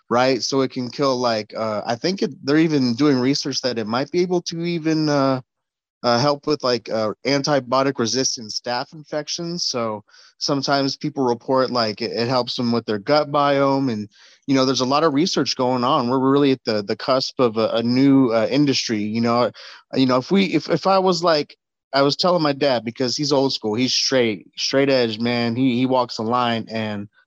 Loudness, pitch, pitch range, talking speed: -20 LUFS, 130 Hz, 120-145 Hz, 215 wpm